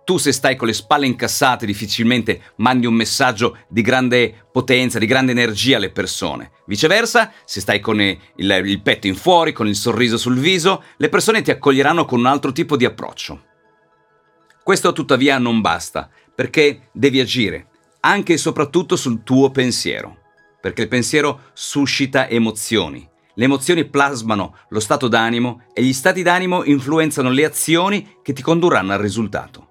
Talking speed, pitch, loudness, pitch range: 160 wpm, 125 Hz, -16 LUFS, 115-150 Hz